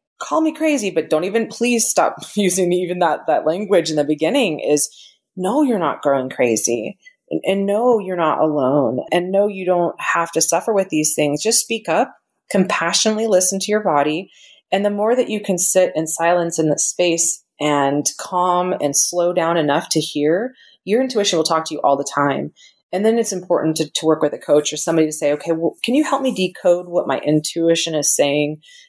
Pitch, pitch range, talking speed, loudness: 175 Hz, 155-205 Hz, 210 wpm, -18 LUFS